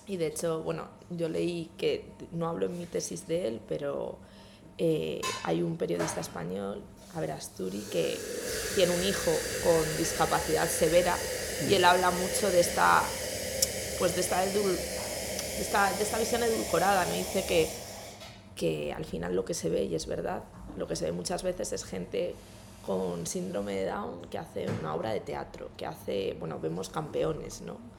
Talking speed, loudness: 175 wpm, -30 LUFS